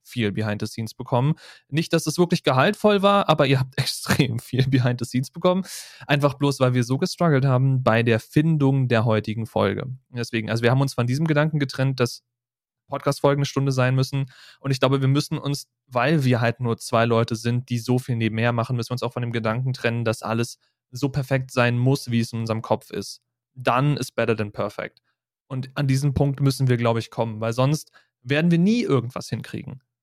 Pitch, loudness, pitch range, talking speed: 130 Hz, -22 LUFS, 115-140 Hz, 215 wpm